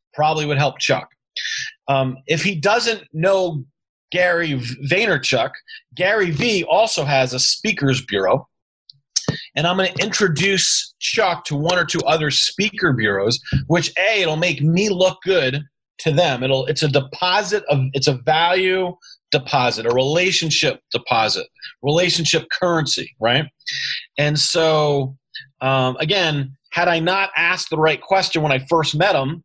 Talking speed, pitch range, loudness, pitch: 145 wpm, 140-185 Hz, -18 LUFS, 160 Hz